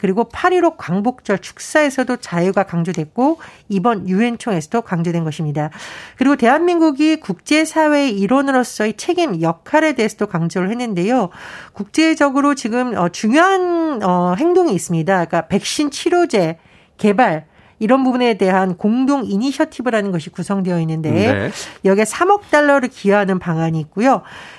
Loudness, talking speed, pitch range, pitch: -16 LUFS, 345 characters per minute, 185-285 Hz, 220 Hz